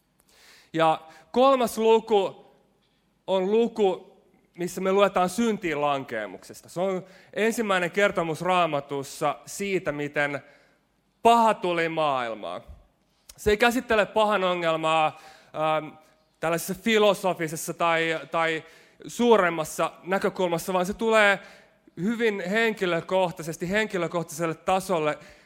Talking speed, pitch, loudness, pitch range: 90 wpm, 180 Hz, -25 LUFS, 160-200 Hz